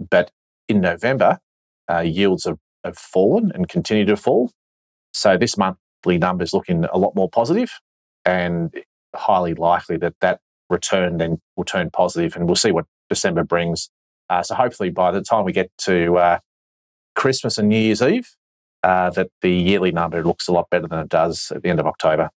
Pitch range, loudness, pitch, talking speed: 85-100 Hz, -19 LUFS, 85 Hz, 190 wpm